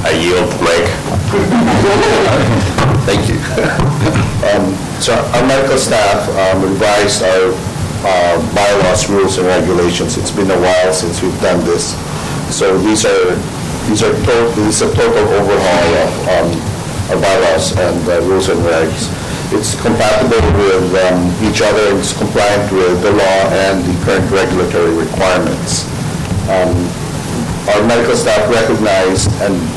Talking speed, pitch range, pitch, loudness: 135 wpm, 90-95 Hz, 95 Hz, -12 LUFS